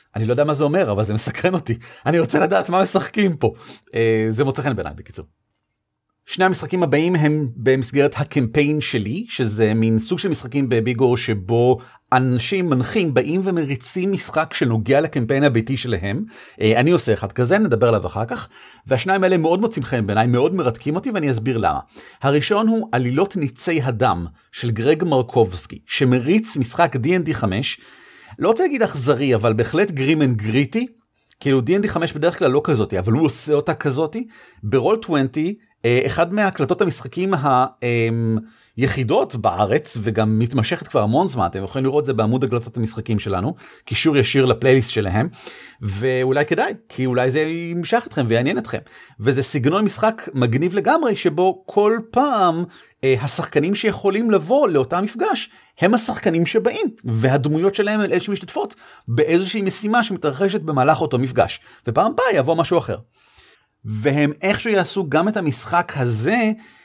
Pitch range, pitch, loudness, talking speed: 120-180 Hz, 145 Hz, -19 LUFS, 155 wpm